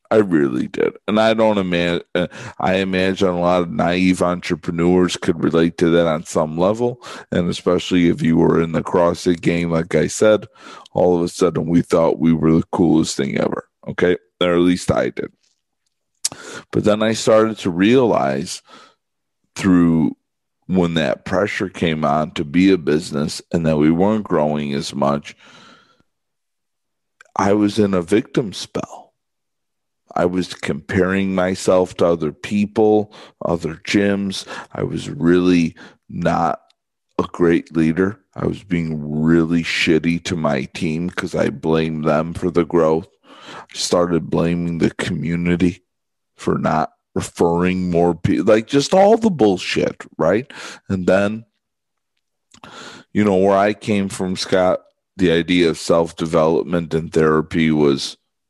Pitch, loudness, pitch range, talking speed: 90 Hz, -18 LUFS, 85-95 Hz, 150 wpm